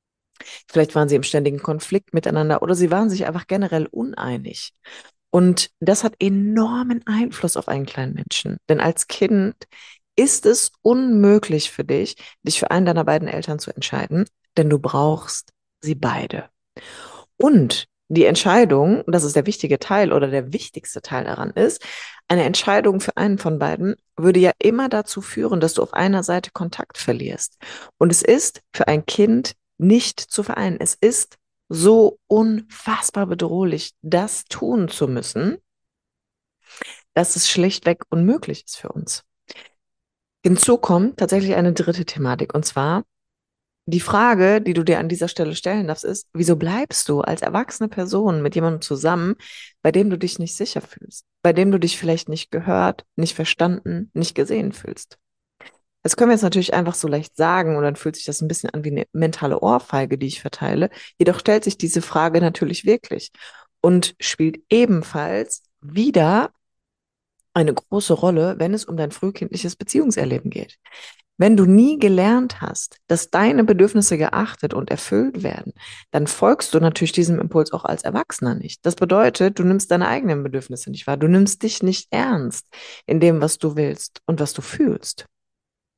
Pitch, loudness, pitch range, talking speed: 175 Hz, -19 LUFS, 160-205 Hz, 165 wpm